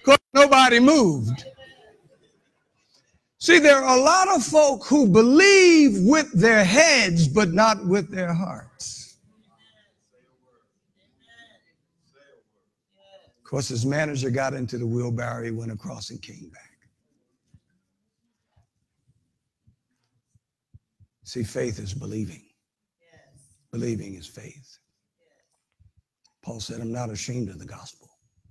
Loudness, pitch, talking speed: -18 LUFS, 135 Hz, 105 wpm